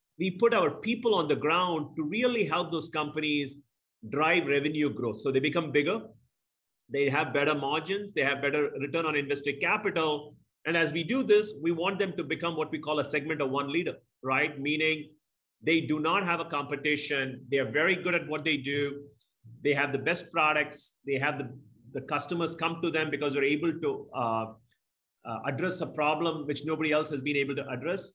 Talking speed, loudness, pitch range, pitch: 200 wpm, -29 LUFS, 140-165 Hz, 150 Hz